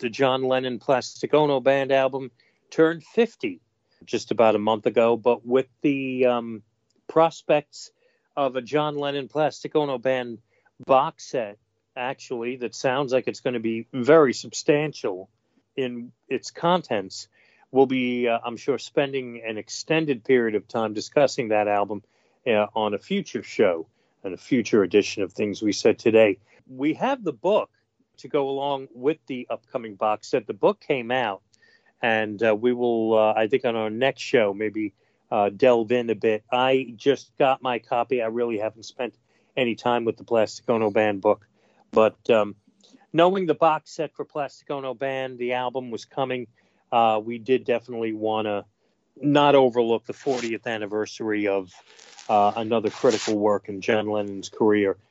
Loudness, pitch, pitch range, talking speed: -24 LUFS, 120 Hz, 110-135 Hz, 165 wpm